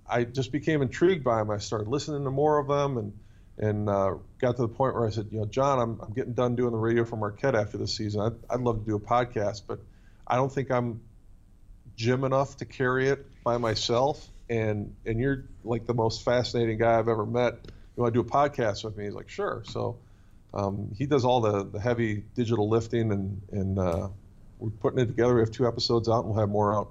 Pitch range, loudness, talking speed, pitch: 105-125 Hz, -28 LUFS, 235 wpm, 115 Hz